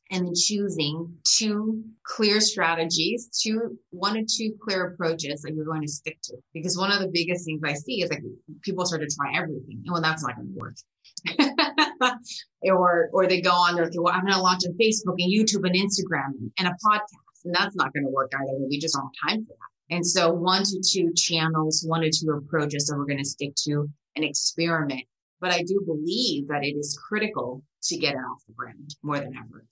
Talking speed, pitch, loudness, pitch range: 215 wpm, 170 Hz, -24 LUFS, 150-190 Hz